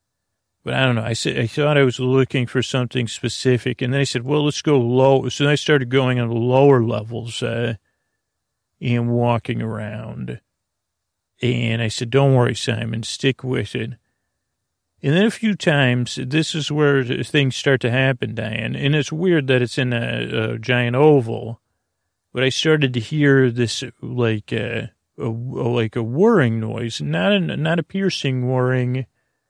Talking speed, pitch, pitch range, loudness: 175 wpm, 125 Hz, 115-135 Hz, -19 LUFS